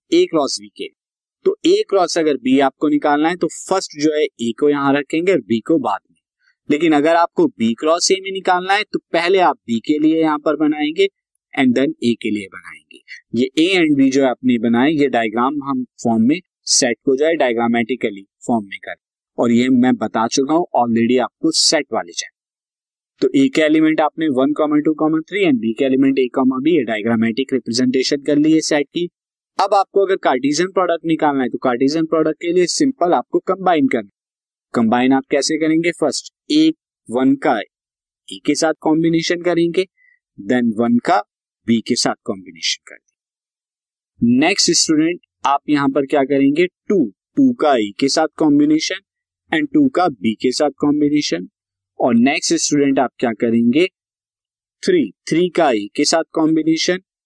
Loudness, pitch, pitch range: -17 LUFS, 155 Hz, 130-190 Hz